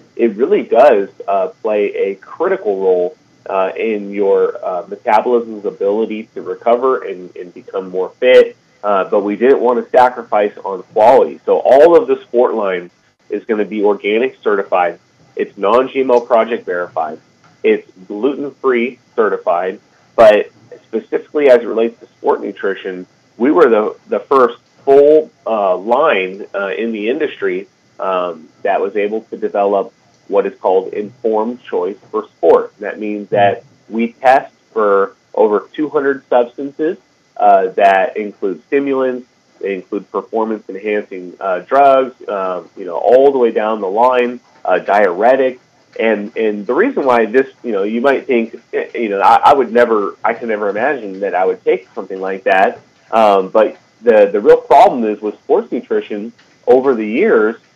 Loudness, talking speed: -14 LUFS, 160 wpm